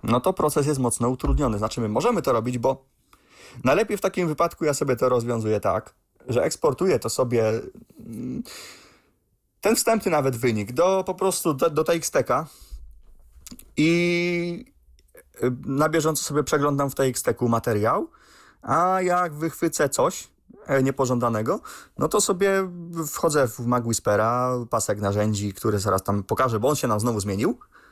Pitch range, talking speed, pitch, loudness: 110-170 Hz, 145 wpm, 130 Hz, -23 LUFS